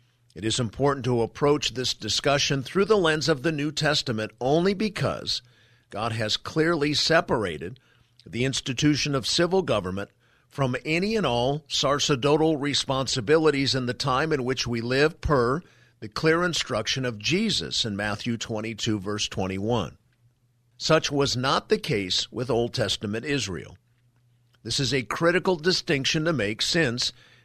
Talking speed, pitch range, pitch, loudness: 145 wpm, 115-150 Hz, 130 Hz, -24 LUFS